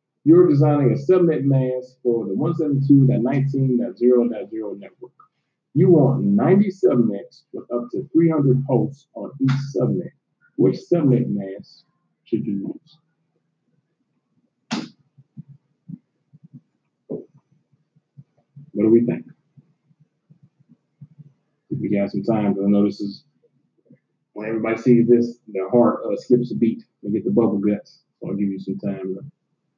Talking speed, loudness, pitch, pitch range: 120 wpm, -20 LUFS, 140 Hz, 120-155 Hz